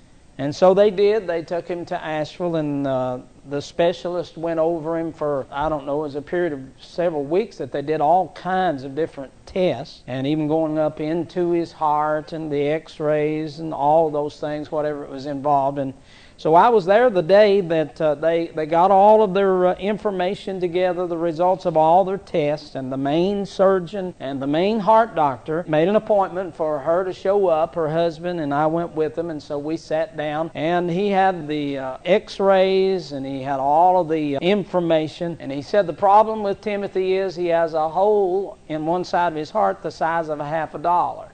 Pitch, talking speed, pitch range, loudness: 165 Hz, 210 wpm, 150-185 Hz, -21 LUFS